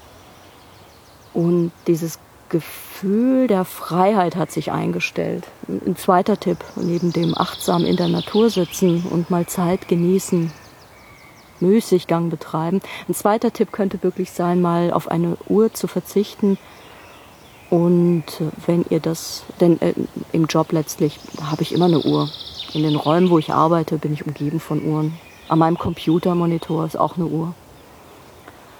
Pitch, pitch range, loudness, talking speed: 170 Hz, 160-185 Hz, -20 LUFS, 140 wpm